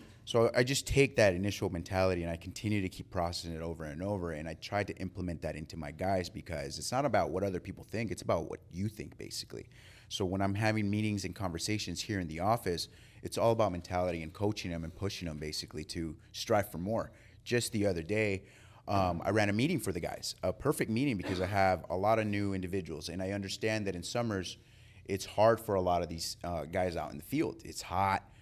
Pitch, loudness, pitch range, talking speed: 95 Hz, -34 LUFS, 85-105 Hz, 230 wpm